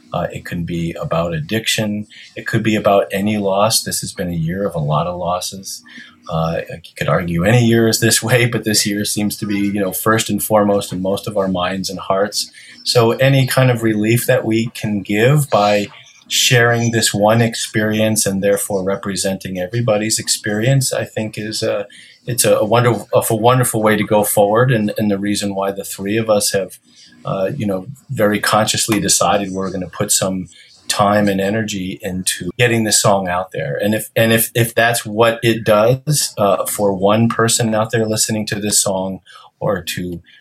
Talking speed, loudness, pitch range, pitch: 195 wpm, -16 LUFS, 100-115 Hz, 105 Hz